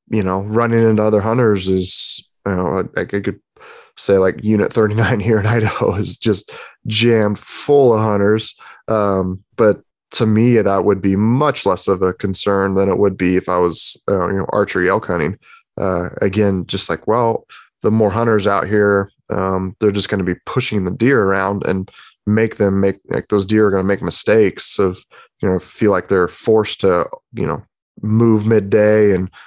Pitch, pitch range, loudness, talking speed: 100 Hz, 95-110 Hz, -16 LUFS, 195 wpm